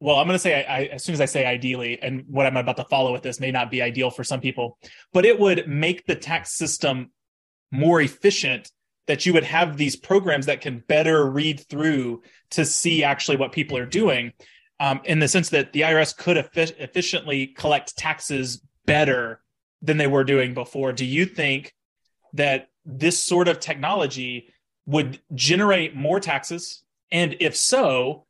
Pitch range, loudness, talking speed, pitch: 130-165 Hz, -22 LUFS, 185 wpm, 145 Hz